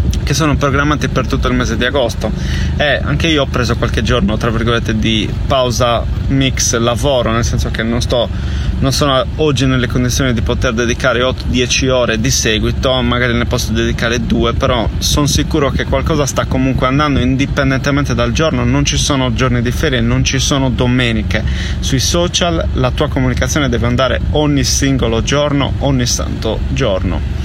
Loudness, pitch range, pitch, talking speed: -14 LUFS, 110-130 Hz, 120 Hz, 170 wpm